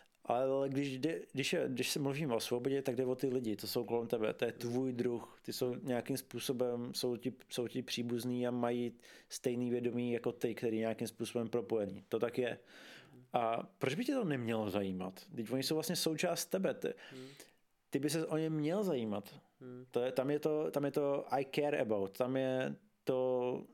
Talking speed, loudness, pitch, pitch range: 200 wpm, -37 LUFS, 125 Hz, 120-140 Hz